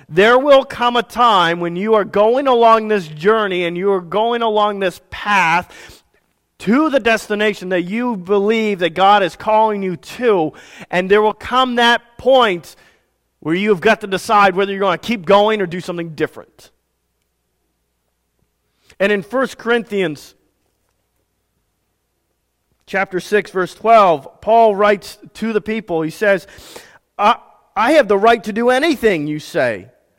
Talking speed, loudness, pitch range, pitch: 150 wpm, -15 LUFS, 175-225 Hz, 205 Hz